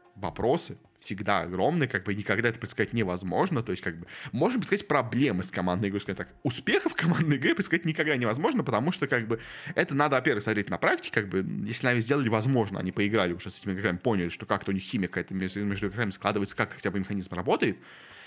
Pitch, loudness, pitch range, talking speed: 105 Hz, -28 LUFS, 95-130 Hz, 210 wpm